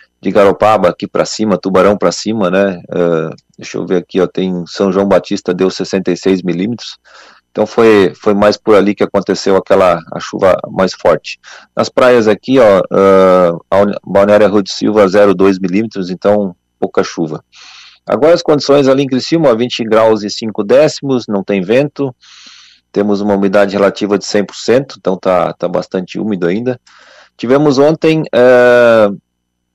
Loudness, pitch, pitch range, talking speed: -11 LUFS, 100 Hz, 95-115 Hz, 160 wpm